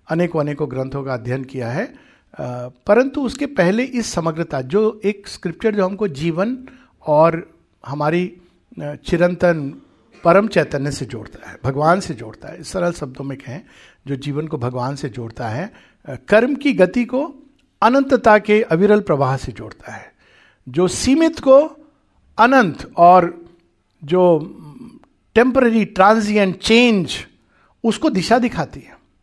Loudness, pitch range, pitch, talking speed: -17 LUFS, 145-225 Hz, 175 Hz, 135 wpm